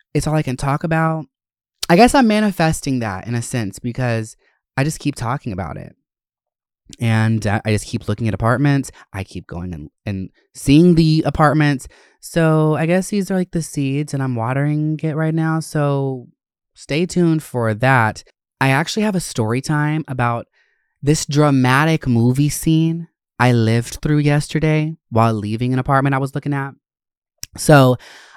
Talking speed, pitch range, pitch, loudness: 165 wpm, 120-155 Hz, 140 Hz, -17 LUFS